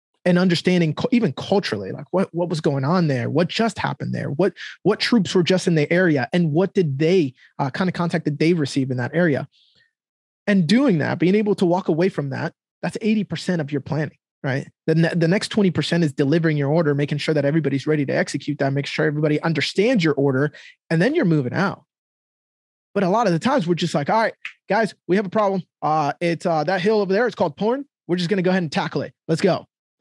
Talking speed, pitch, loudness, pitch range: 240 wpm, 170 Hz, -21 LUFS, 150-190 Hz